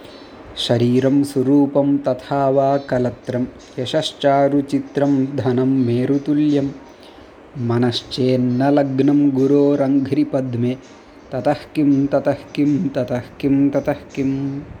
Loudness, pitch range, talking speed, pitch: -18 LUFS, 130-145 Hz, 75 wpm, 140 Hz